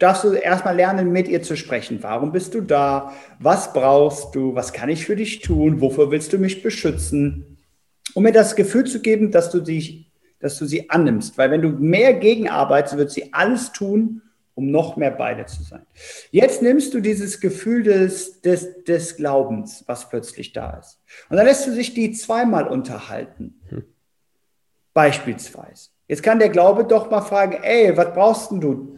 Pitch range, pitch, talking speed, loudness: 140-215 Hz, 180 Hz, 175 wpm, -18 LUFS